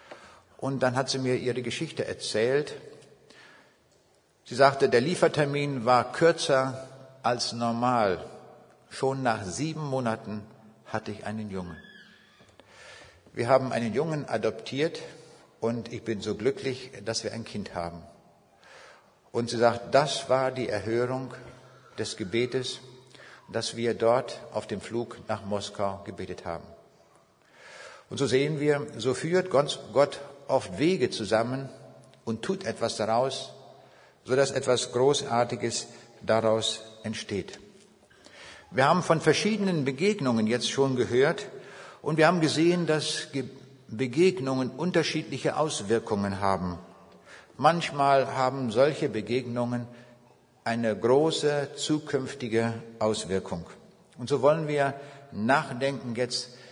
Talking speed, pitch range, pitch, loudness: 115 wpm, 115-140 Hz, 125 Hz, -27 LUFS